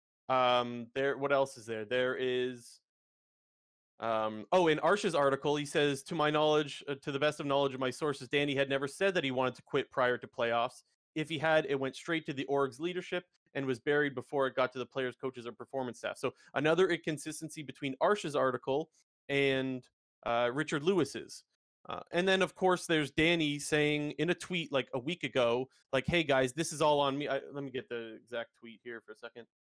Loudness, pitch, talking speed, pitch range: -33 LUFS, 140 Hz, 215 wpm, 125-155 Hz